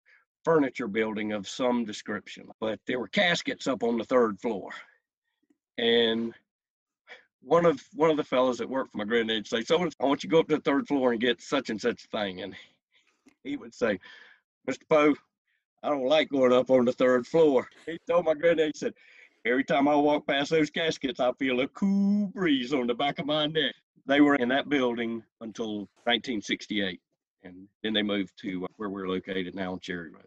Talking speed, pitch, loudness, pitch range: 200 wpm, 130 Hz, -27 LUFS, 115-160 Hz